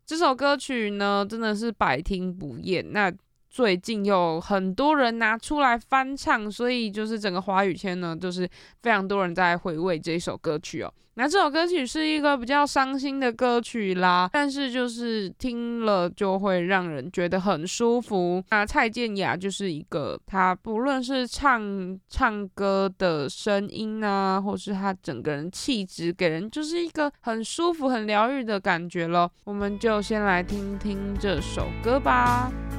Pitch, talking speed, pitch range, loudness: 205 Hz, 245 characters per minute, 185-240 Hz, -25 LUFS